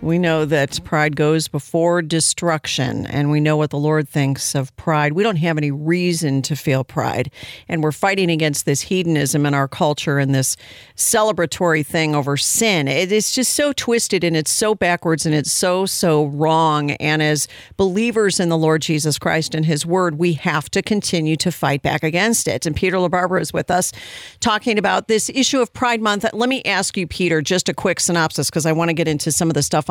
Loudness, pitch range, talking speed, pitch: -18 LUFS, 150-185 Hz, 210 wpm, 160 Hz